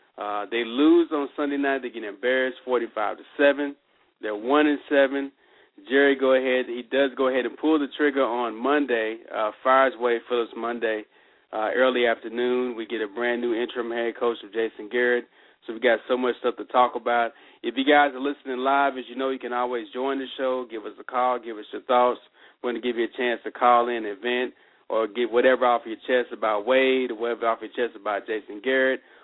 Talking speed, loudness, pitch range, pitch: 220 wpm, -24 LUFS, 120-135 Hz, 125 Hz